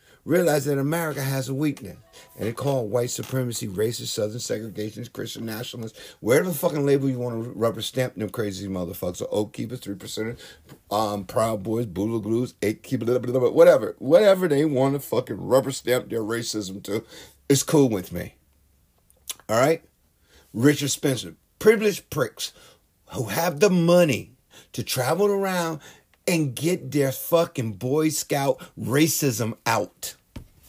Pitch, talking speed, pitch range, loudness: 125 Hz, 150 wpm, 105-145 Hz, -24 LUFS